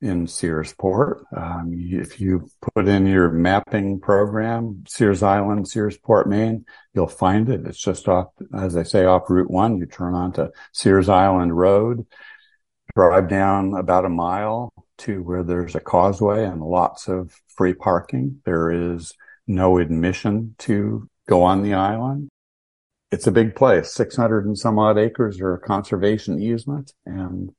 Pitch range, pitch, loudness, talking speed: 90-110 Hz, 95 Hz, -20 LUFS, 150 wpm